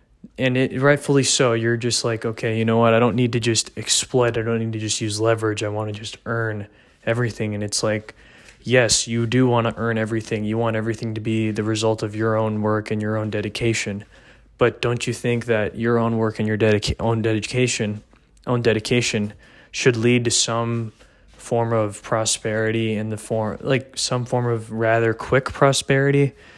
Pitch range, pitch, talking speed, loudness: 110-120 Hz, 115 Hz, 195 wpm, -21 LUFS